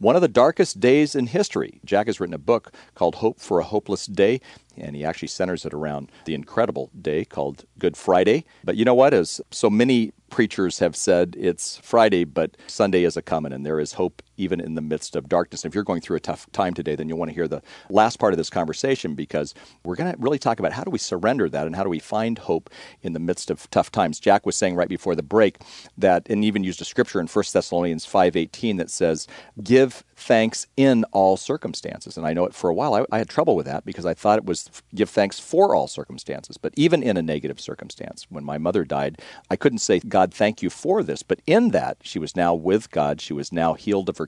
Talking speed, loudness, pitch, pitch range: 245 wpm, -22 LUFS, 95 Hz, 80-115 Hz